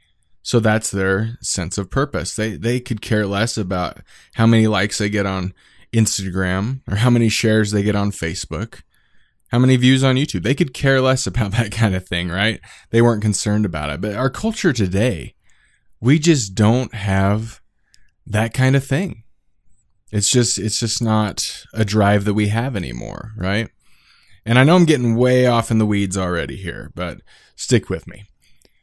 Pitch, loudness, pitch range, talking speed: 110 Hz, -18 LUFS, 100-120 Hz, 180 wpm